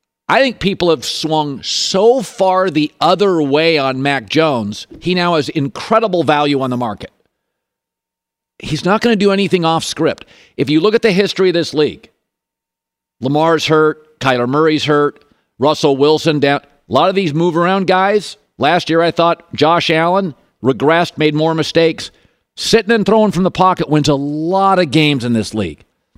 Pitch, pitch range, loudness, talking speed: 160 Hz, 145-185 Hz, -14 LUFS, 175 wpm